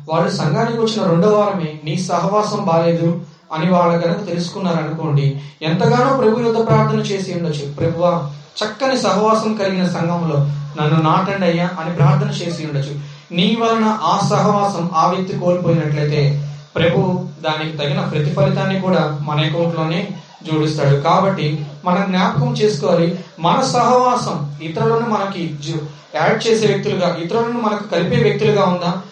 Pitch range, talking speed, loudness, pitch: 155-195 Hz, 125 wpm, -17 LUFS, 170 Hz